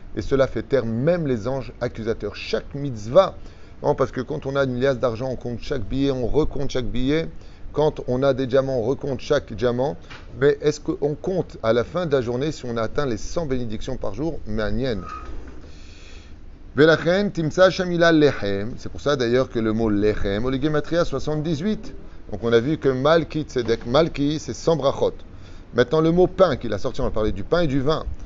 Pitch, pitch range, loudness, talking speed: 130 Hz, 110-150 Hz, -22 LUFS, 200 wpm